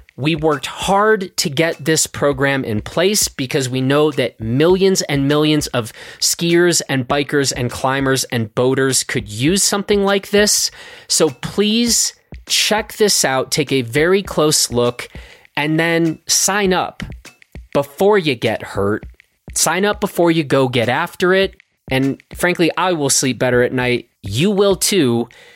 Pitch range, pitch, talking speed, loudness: 130-190 Hz, 150 Hz, 155 wpm, -16 LUFS